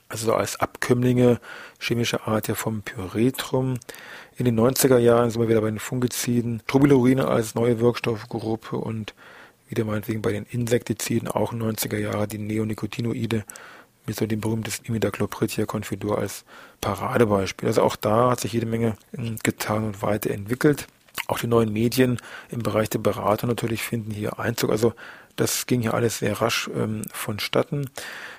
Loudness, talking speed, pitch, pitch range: -24 LUFS, 155 wpm, 115 Hz, 110-120 Hz